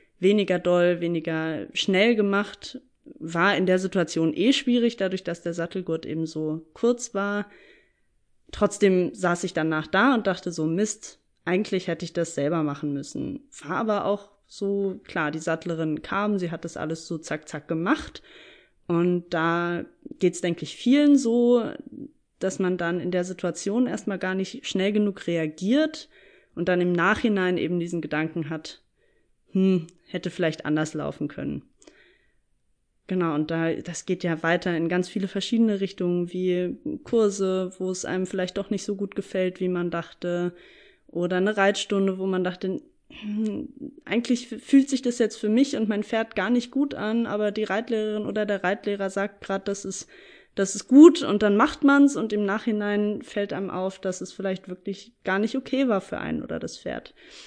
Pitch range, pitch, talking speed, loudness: 175-220 Hz, 195 Hz, 175 wpm, -25 LUFS